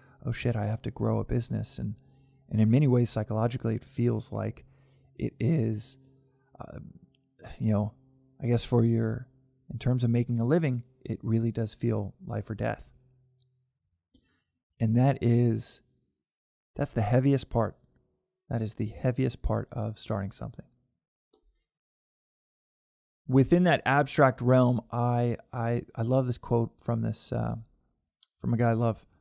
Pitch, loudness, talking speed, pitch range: 120 Hz, -28 LUFS, 150 wpm, 110-130 Hz